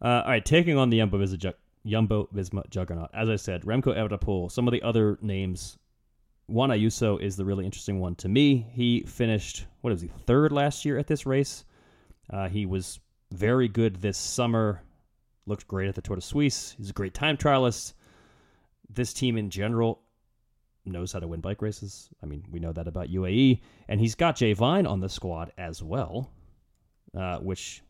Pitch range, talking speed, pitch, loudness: 95-120 Hz, 190 wpm, 105 Hz, -27 LUFS